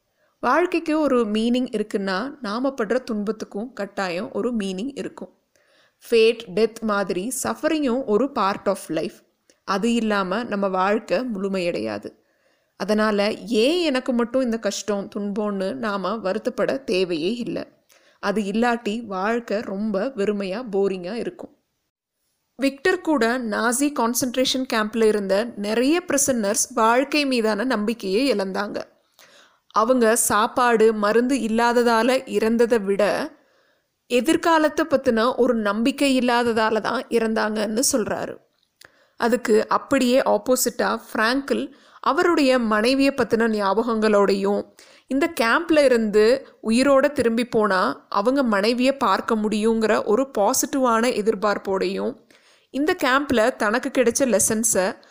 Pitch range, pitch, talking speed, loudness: 210-260 Hz, 230 Hz, 100 wpm, -21 LUFS